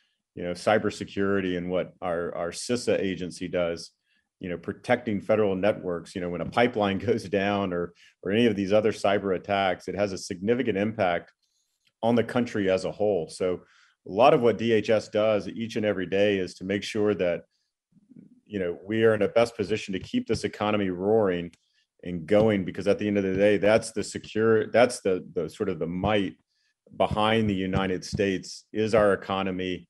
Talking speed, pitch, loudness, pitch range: 195 wpm, 100 Hz, -26 LUFS, 95-110 Hz